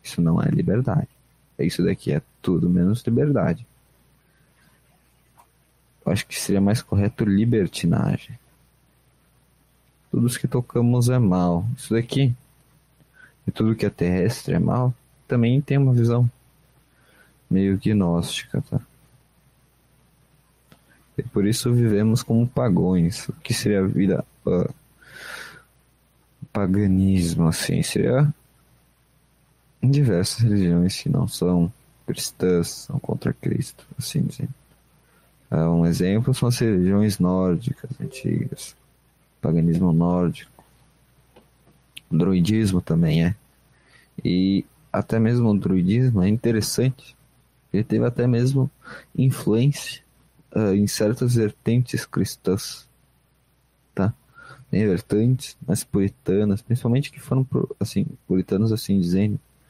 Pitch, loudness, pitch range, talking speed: 115 Hz, -22 LUFS, 95-130 Hz, 105 wpm